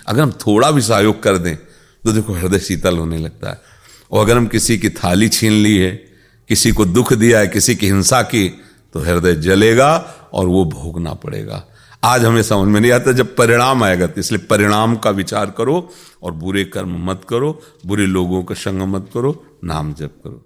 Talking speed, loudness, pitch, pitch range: 200 wpm, -14 LUFS, 105 Hz, 95-115 Hz